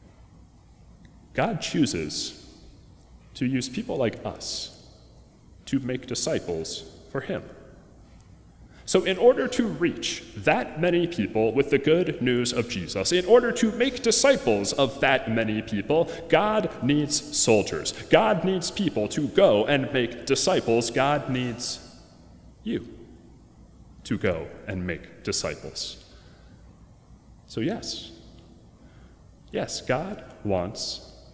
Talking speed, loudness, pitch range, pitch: 115 wpm, -24 LUFS, 115-175 Hz, 140 Hz